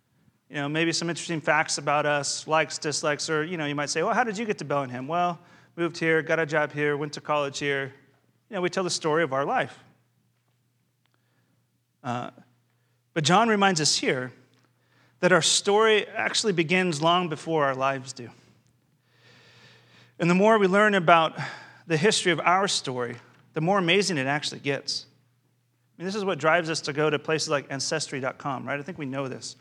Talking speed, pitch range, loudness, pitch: 195 wpm, 135-175 Hz, -25 LUFS, 155 Hz